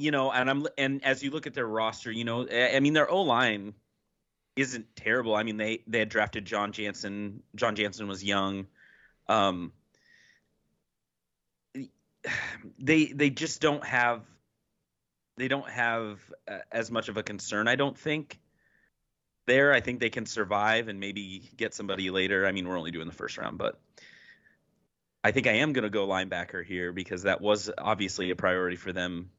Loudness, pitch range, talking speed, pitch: -29 LUFS, 95-125 Hz, 175 wpm, 110 Hz